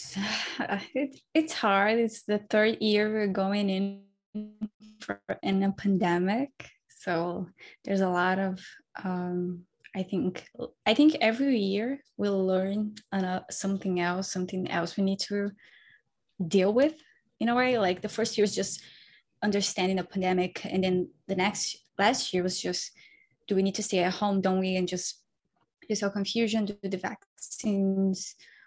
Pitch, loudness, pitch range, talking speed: 195 Hz, -28 LUFS, 185-215 Hz, 160 wpm